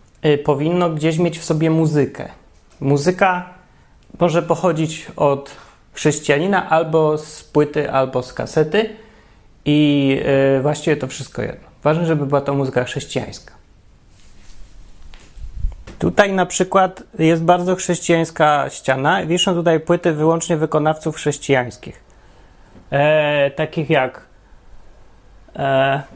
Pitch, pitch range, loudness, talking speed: 155 Hz, 140-170 Hz, -18 LUFS, 105 wpm